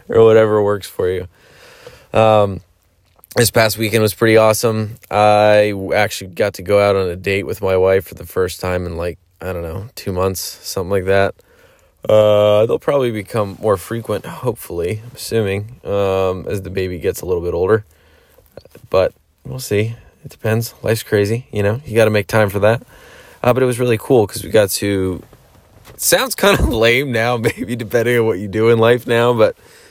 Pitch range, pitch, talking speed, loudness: 95-115 Hz, 105 Hz, 195 wpm, -16 LUFS